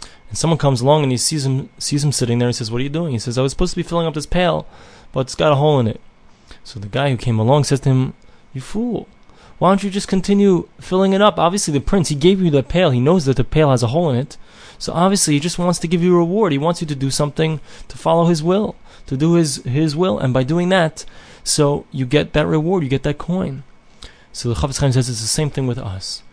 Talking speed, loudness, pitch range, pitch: 275 wpm, -17 LUFS, 135-175 Hz, 150 Hz